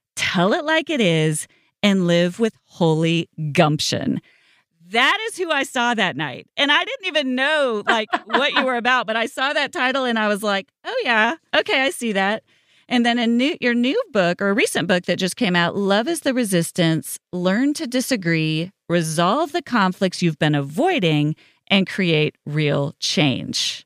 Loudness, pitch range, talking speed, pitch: -20 LUFS, 170-255 Hz, 185 wpm, 205 Hz